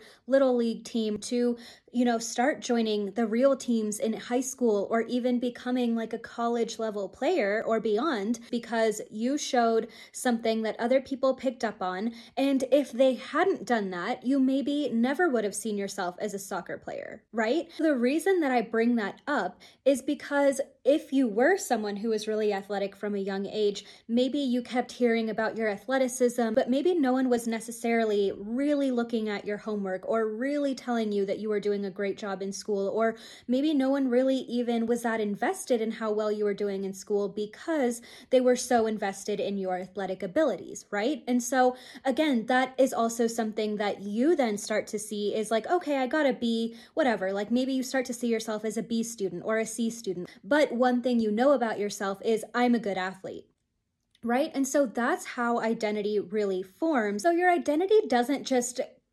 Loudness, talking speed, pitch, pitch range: -28 LUFS, 195 wpm, 235 Hz, 210-260 Hz